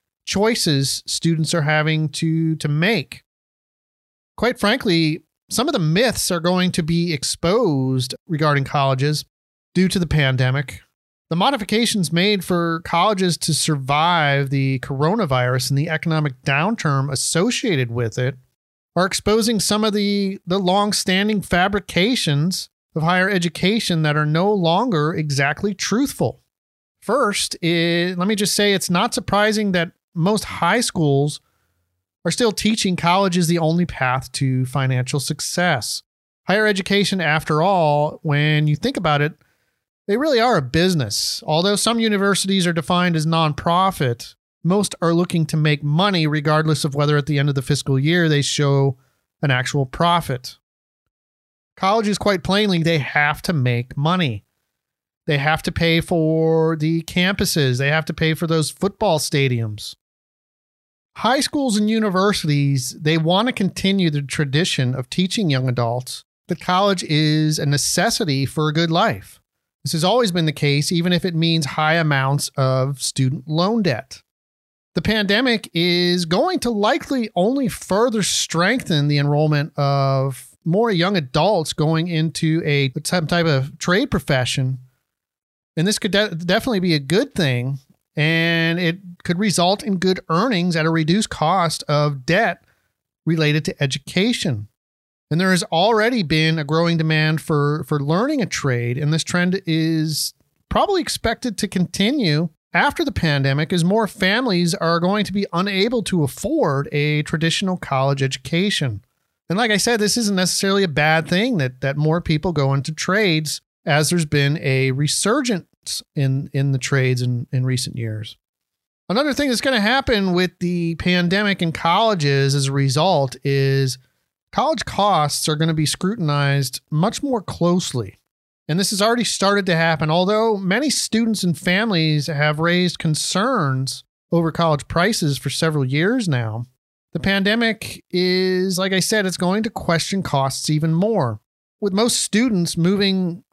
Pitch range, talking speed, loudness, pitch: 145-190 Hz, 155 wpm, -19 LUFS, 165 Hz